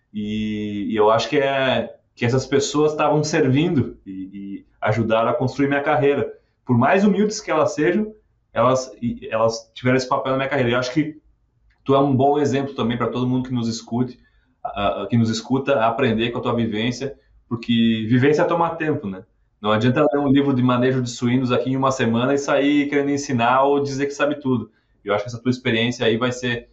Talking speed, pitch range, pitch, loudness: 210 wpm, 115-140 Hz, 125 Hz, -20 LUFS